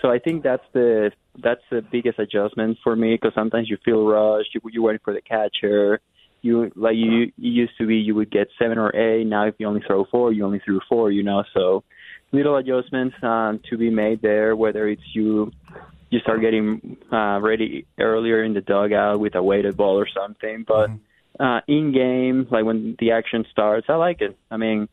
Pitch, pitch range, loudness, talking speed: 110 Hz, 105-115 Hz, -21 LUFS, 210 wpm